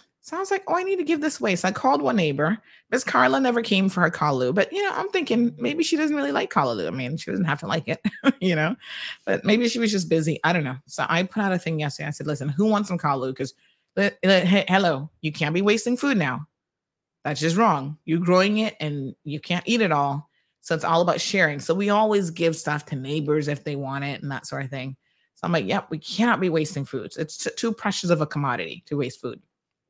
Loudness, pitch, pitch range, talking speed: -23 LUFS, 170 Hz, 150-215 Hz, 255 wpm